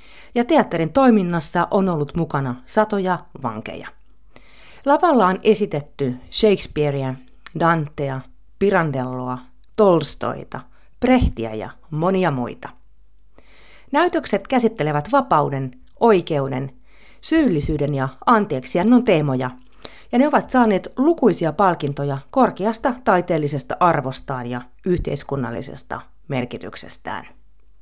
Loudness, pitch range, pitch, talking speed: -20 LUFS, 130-210 Hz, 160 Hz, 85 wpm